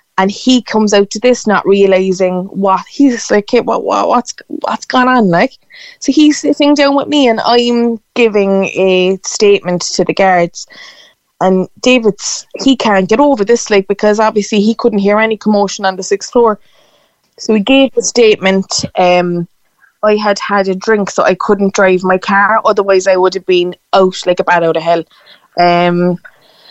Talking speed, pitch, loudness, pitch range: 185 wpm, 205 Hz, -11 LUFS, 190-235 Hz